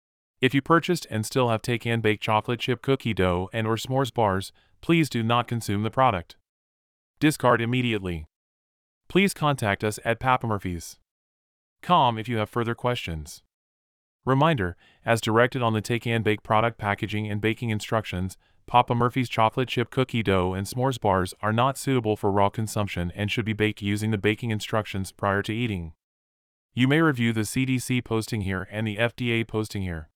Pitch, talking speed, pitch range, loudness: 110 Hz, 160 wpm, 95-120 Hz, -25 LUFS